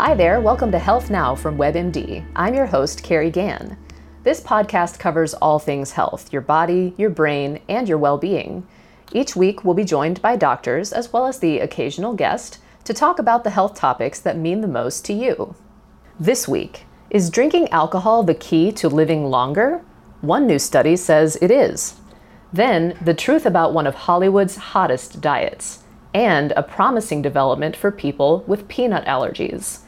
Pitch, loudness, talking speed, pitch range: 180 Hz, -18 LUFS, 175 wpm, 160-215 Hz